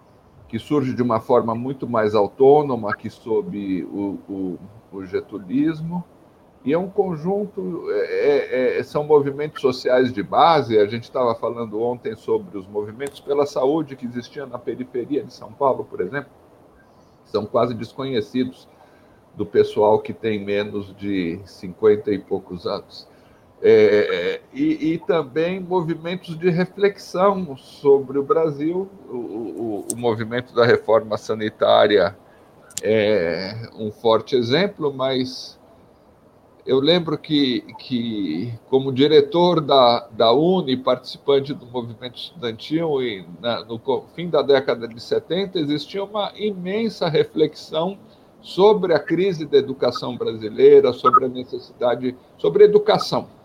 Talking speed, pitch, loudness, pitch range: 130 wpm, 150 Hz, -20 LUFS, 120-200 Hz